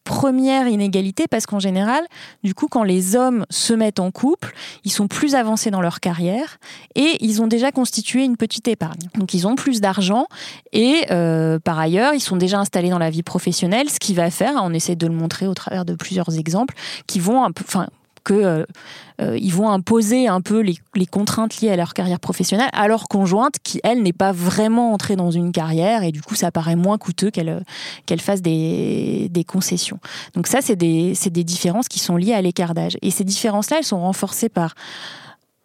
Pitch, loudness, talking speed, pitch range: 195 Hz, -19 LUFS, 205 wpm, 180-225 Hz